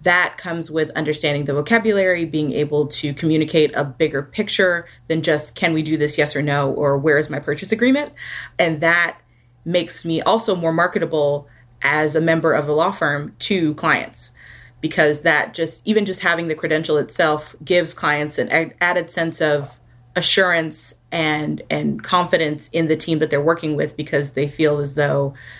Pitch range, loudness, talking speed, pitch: 145-170 Hz, -19 LUFS, 175 wpm, 155 Hz